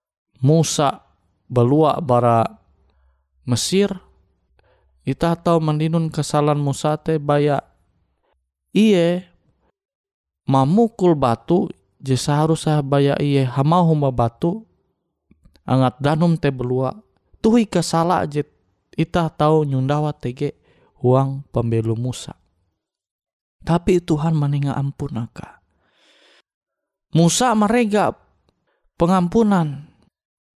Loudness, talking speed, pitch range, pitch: -19 LUFS, 80 wpm, 130-170 Hz, 150 Hz